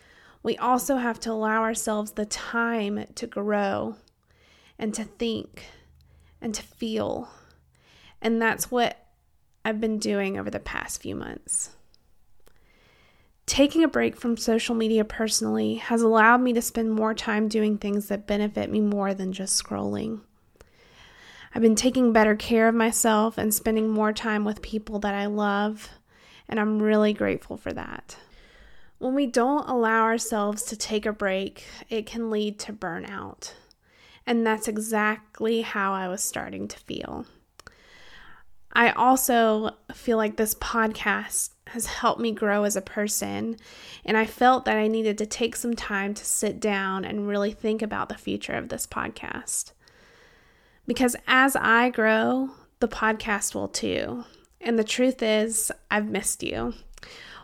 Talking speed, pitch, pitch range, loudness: 150 wpm, 220 Hz, 210-230 Hz, -25 LUFS